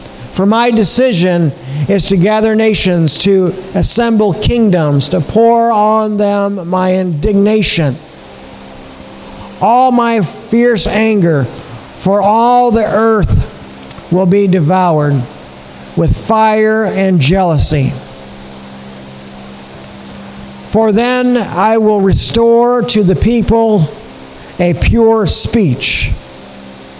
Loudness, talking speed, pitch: -10 LUFS, 95 wpm, 185 Hz